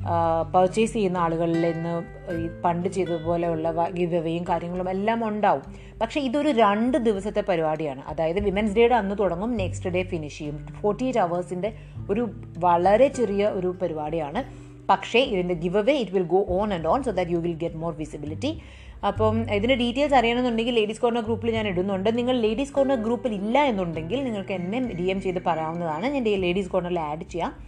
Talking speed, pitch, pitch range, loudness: 165 wpm, 185 Hz, 170-225 Hz, -24 LUFS